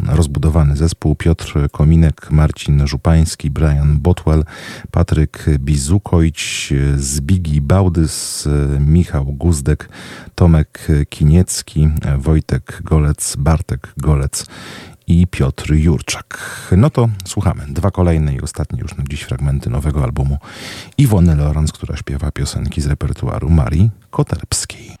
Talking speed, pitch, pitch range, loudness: 110 wpm, 80 Hz, 75-90 Hz, -16 LUFS